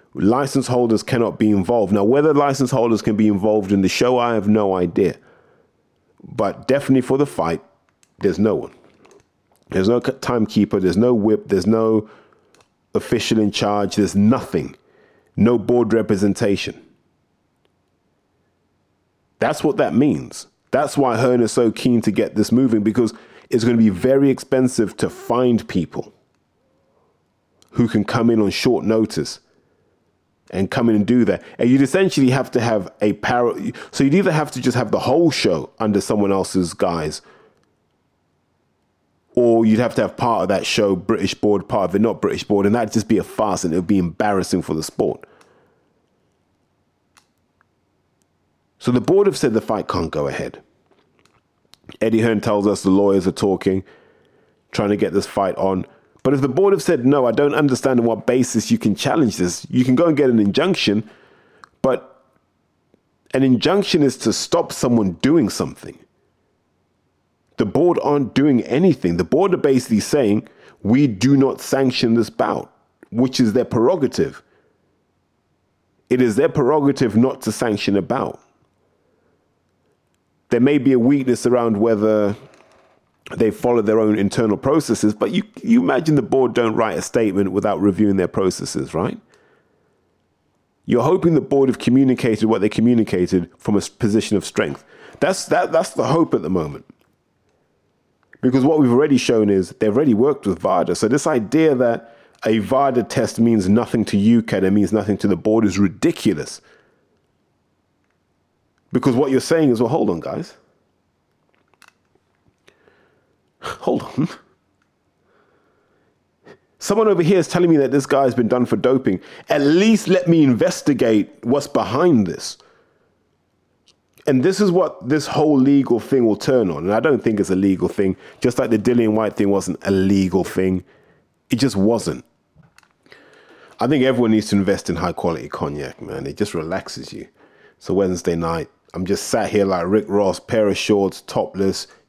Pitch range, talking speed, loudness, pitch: 100-130 Hz, 165 wpm, -18 LUFS, 115 Hz